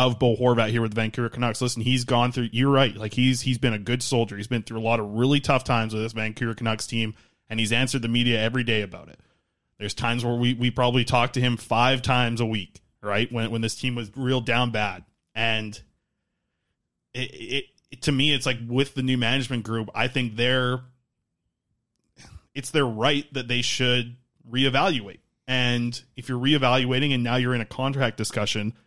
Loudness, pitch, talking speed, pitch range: -24 LUFS, 120 Hz, 210 wpm, 115-130 Hz